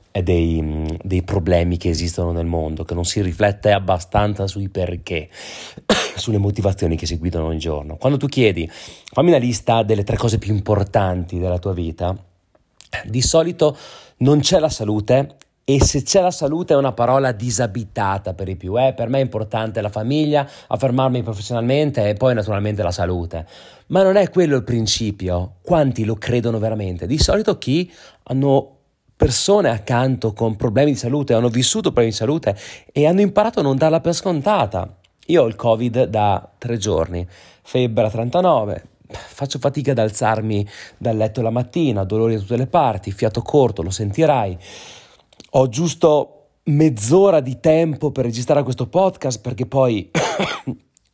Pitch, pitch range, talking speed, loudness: 115 Hz, 100-140 Hz, 165 wpm, -18 LUFS